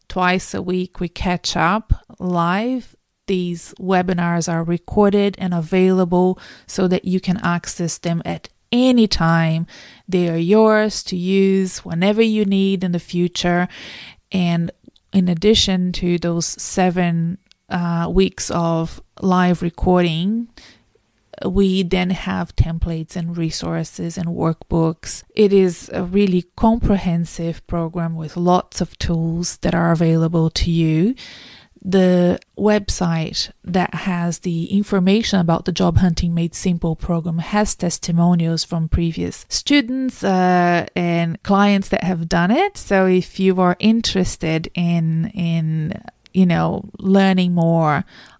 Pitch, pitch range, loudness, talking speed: 180 Hz, 170-195 Hz, -18 LUFS, 125 wpm